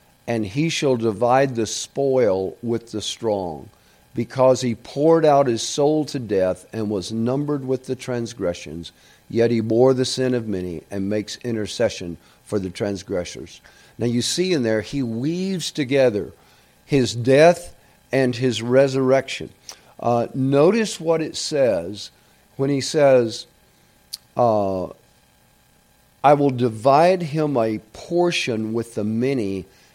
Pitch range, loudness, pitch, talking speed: 105-140 Hz, -21 LUFS, 120 Hz, 135 wpm